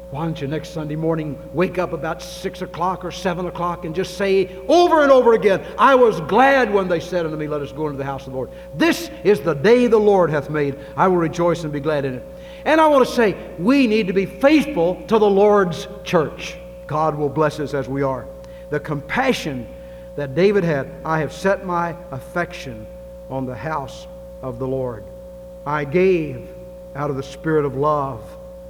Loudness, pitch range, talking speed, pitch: -19 LUFS, 145-185 Hz, 205 wpm, 175 Hz